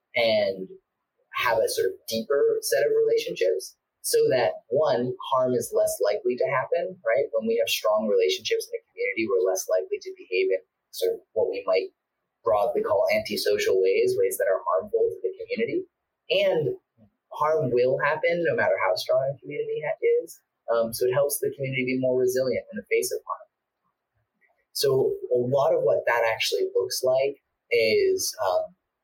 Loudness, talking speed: -25 LUFS, 175 wpm